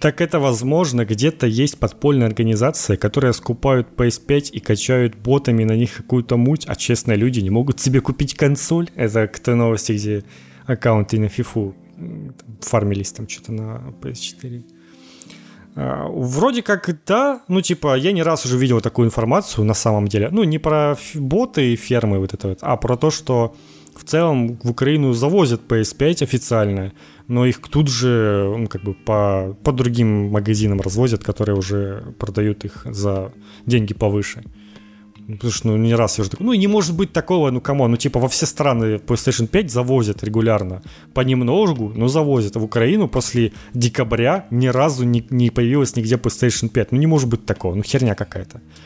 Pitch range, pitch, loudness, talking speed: 105-135 Hz, 120 Hz, -18 LUFS, 170 wpm